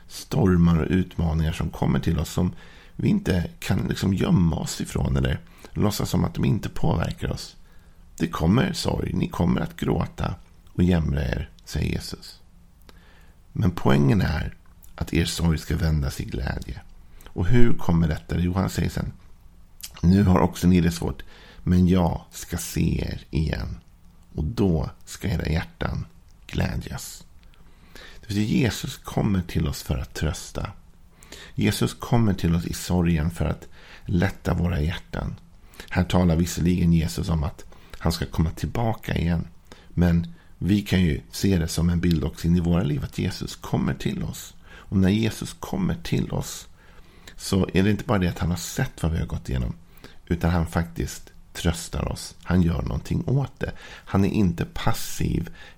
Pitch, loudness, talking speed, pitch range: 85 Hz, -25 LUFS, 165 wpm, 80-90 Hz